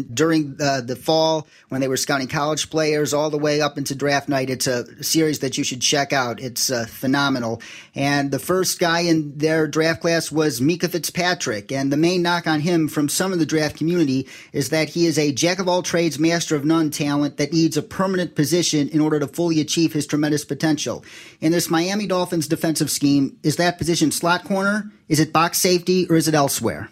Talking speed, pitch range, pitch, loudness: 215 wpm, 140-170 Hz, 155 Hz, -20 LUFS